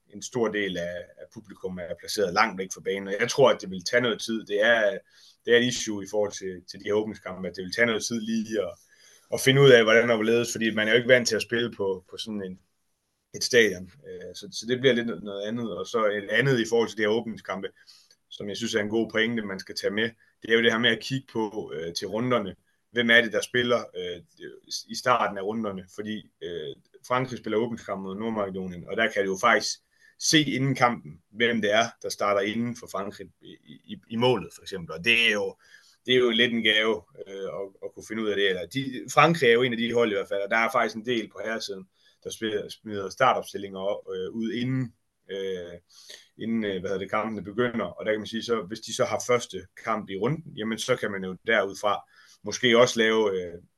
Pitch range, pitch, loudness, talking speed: 100-125 Hz, 115 Hz, -25 LUFS, 245 wpm